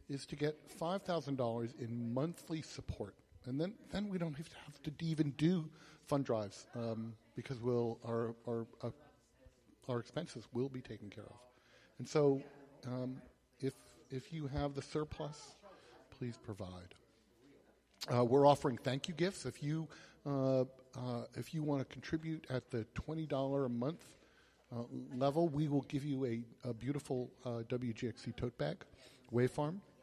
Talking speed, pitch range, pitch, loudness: 160 wpm, 120-150 Hz, 130 Hz, -40 LUFS